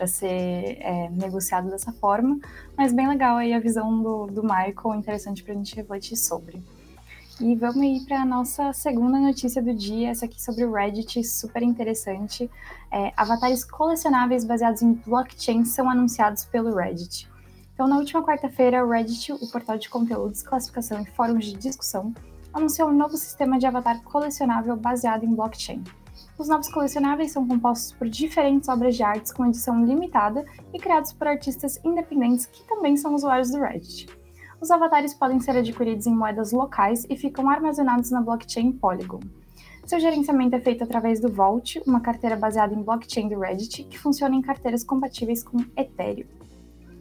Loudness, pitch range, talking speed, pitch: -24 LUFS, 220-275 Hz, 170 wpm, 240 Hz